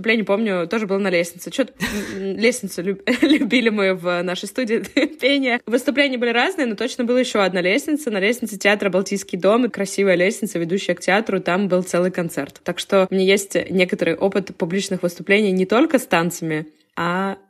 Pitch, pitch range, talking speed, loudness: 195 Hz, 185-230 Hz, 180 wpm, -19 LUFS